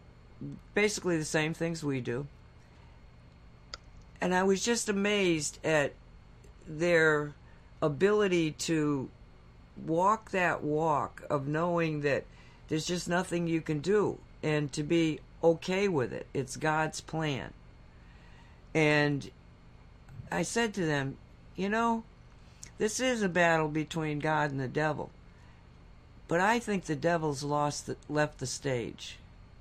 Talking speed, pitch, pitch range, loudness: 125 wpm, 155 Hz, 135-170 Hz, -30 LUFS